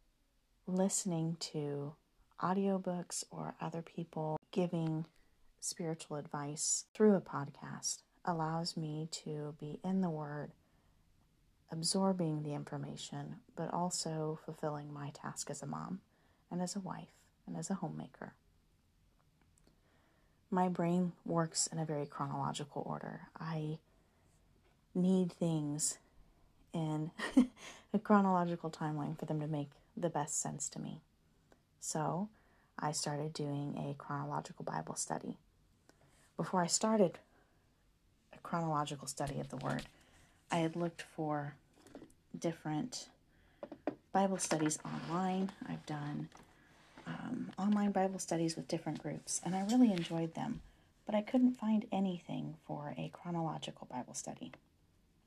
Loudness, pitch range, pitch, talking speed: -38 LUFS, 145-180 Hz, 160 Hz, 120 wpm